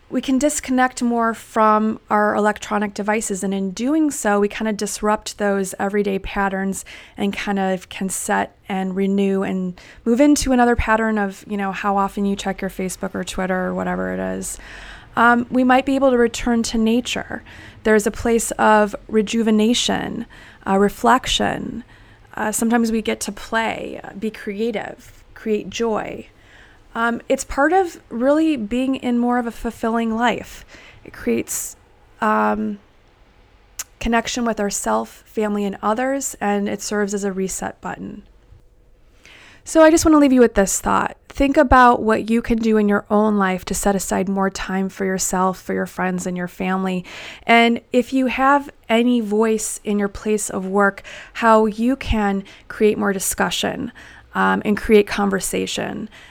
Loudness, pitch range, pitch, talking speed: -19 LUFS, 195-235 Hz, 215 Hz, 165 wpm